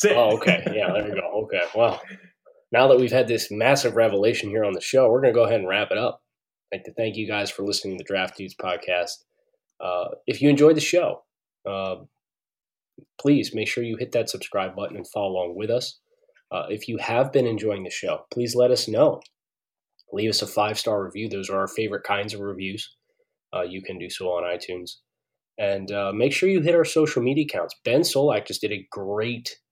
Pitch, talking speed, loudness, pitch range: 110 Hz, 220 wpm, -23 LUFS, 100-155 Hz